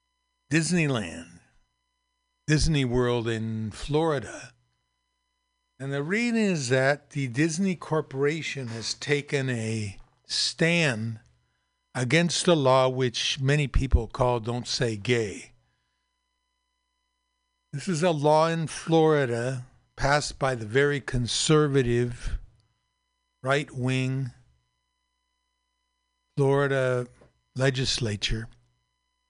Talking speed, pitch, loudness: 85 wpm, 125 Hz, -26 LUFS